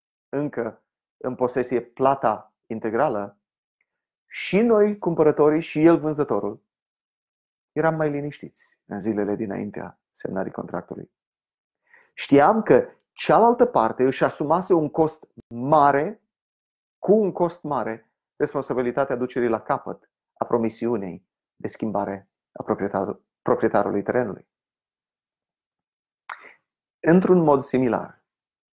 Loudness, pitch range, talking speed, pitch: -22 LUFS, 115-160 Hz, 100 wpm, 140 Hz